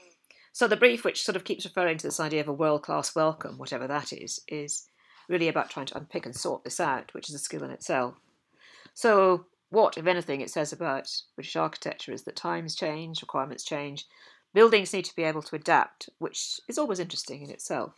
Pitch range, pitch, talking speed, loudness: 150-190 Hz, 165 Hz, 210 wpm, -28 LUFS